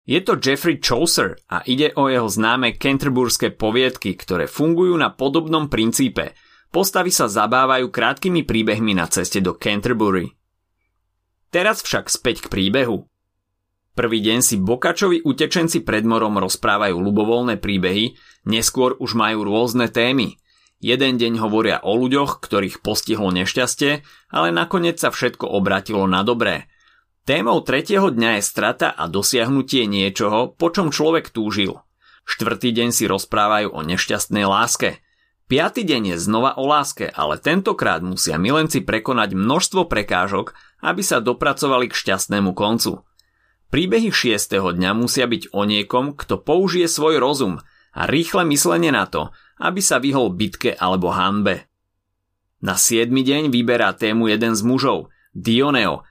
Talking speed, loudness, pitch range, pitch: 140 wpm, -18 LUFS, 100-135 Hz, 115 Hz